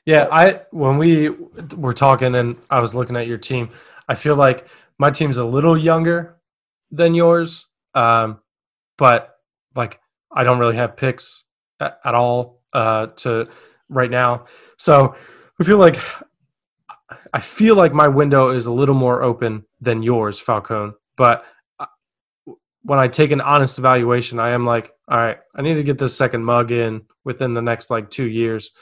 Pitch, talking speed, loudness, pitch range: 125 Hz, 170 wpm, -17 LUFS, 120-150 Hz